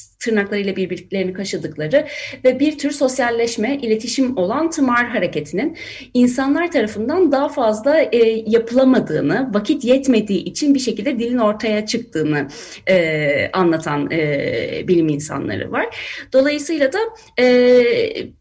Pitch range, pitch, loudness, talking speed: 190-280 Hz, 235 Hz, -18 LUFS, 110 wpm